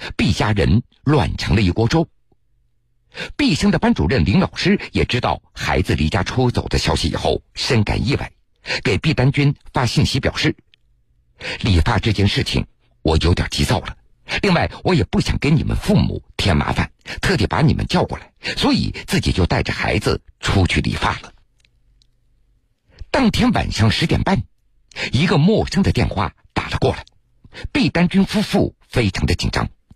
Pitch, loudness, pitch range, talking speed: 115 Hz, -18 LUFS, 90-125 Hz, 240 characters per minute